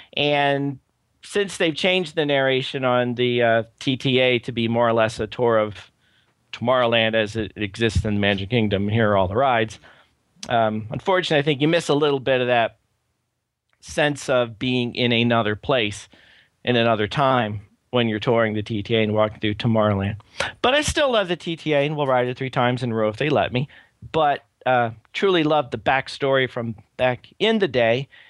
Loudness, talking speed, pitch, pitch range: -21 LUFS, 190 wpm, 120 Hz, 110-140 Hz